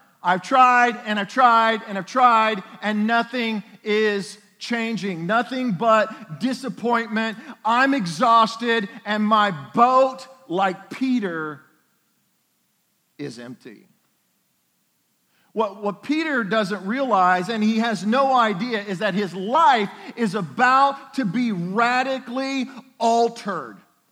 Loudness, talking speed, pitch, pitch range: -21 LUFS, 110 wpm, 225 Hz, 205-245 Hz